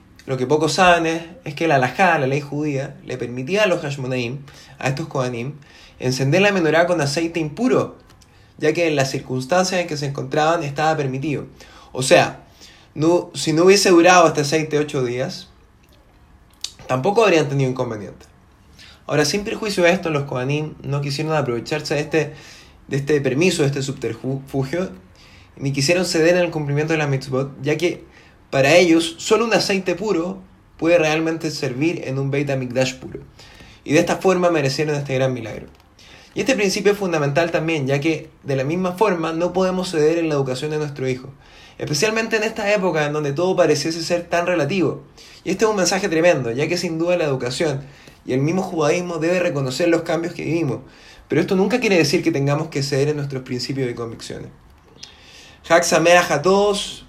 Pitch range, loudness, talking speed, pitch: 135-175 Hz, -19 LUFS, 180 wpm, 155 Hz